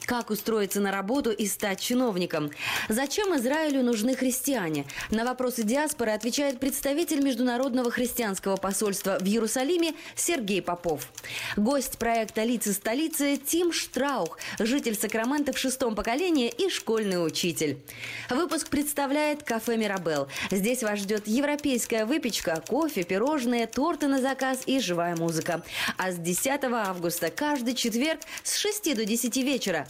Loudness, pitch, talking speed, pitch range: -27 LUFS, 240 Hz, 130 wpm, 200-275 Hz